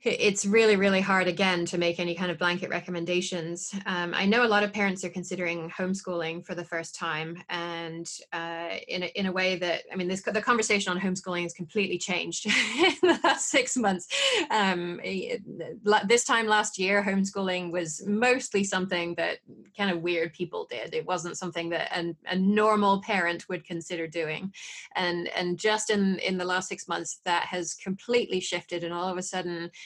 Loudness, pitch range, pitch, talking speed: -27 LUFS, 175-205 Hz, 185 Hz, 190 wpm